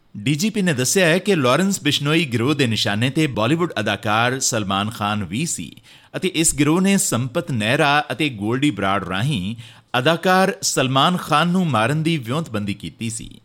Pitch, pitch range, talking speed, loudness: 140 Hz, 110-160 Hz, 150 wpm, -19 LUFS